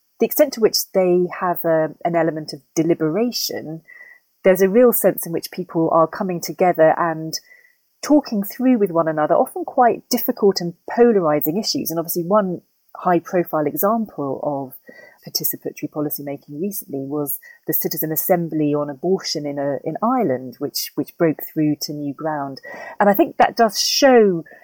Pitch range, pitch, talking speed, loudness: 155-215 Hz, 170 Hz, 160 wpm, -19 LUFS